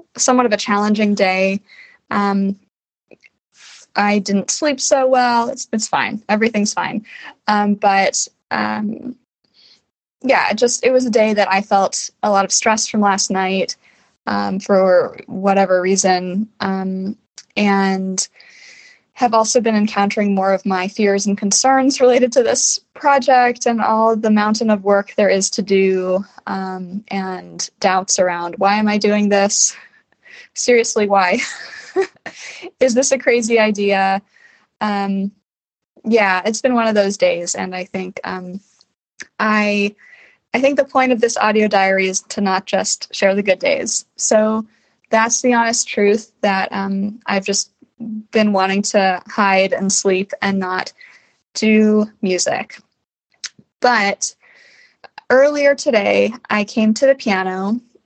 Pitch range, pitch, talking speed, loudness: 195-240 Hz, 210 Hz, 145 wpm, -16 LUFS